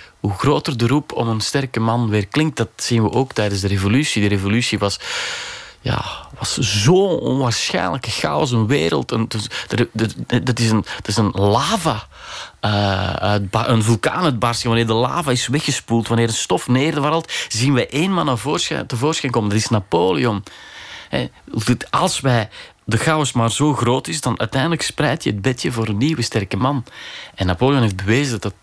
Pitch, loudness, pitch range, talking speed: 115 Hz, -18 LUFS, 110-140 Hz, 170 wpm